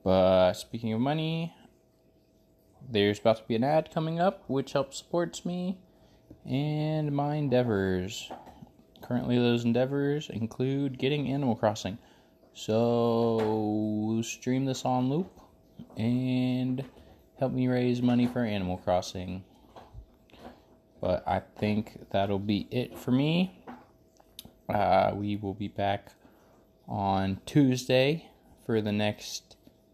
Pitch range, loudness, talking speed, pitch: 105-135 Hz, -29 LUFS, 115 wpm, 120 Hz